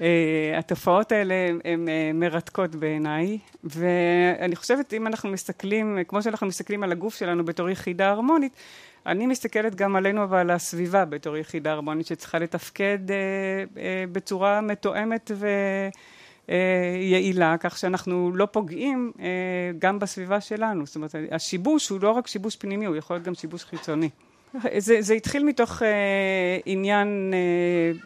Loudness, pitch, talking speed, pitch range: -25 LUFS, 190 Hz, 145 wpm, 175-205 Hz